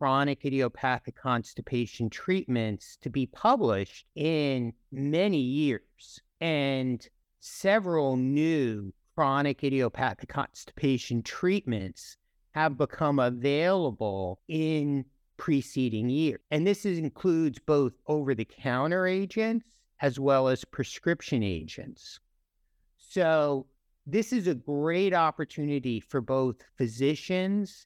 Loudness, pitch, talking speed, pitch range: -29 LUFS, 140 Hz, 95 wpm, 125-160 Hz